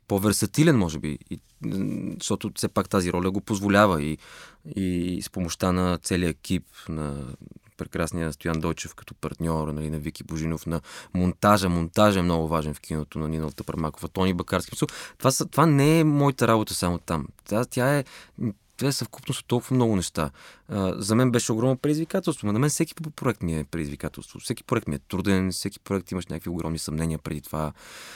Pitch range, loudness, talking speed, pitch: 80-115 Hz, -26 LUFS, 185 wpm, 95 Hz